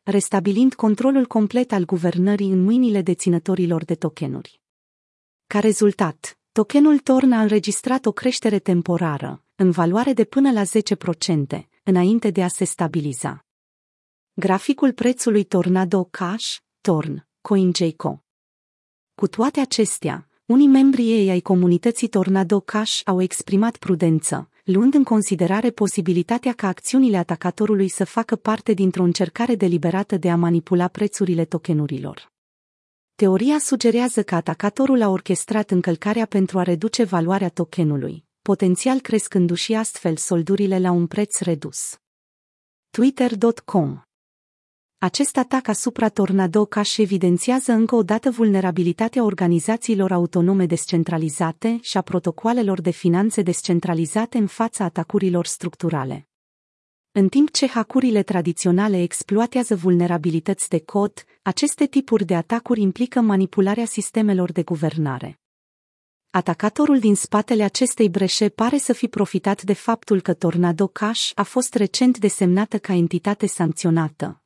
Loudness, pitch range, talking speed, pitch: -20 LUFS, 180-225 Hz, 120 wpm, 200 Hz